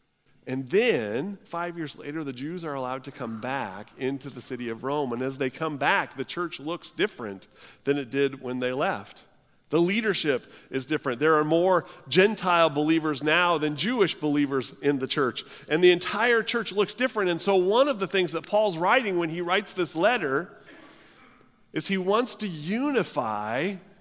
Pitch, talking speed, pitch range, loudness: 160 Hz, 180 wpm, 140-185 Hz, -26 LUFS